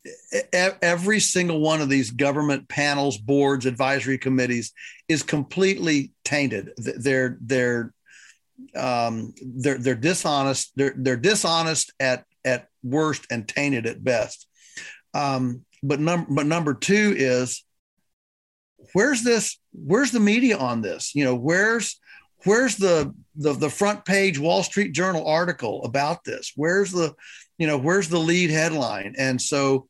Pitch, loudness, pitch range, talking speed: 145 Hz, -22 LUFS, 130-180 Hz, 135 wpm